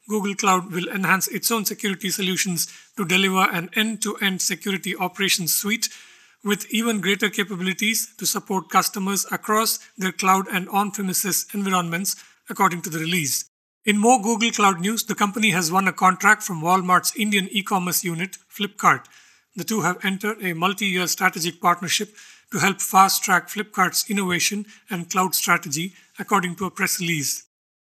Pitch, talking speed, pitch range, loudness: 195 Hz, 165 wpm, 180-205 Hz, -21 LUFS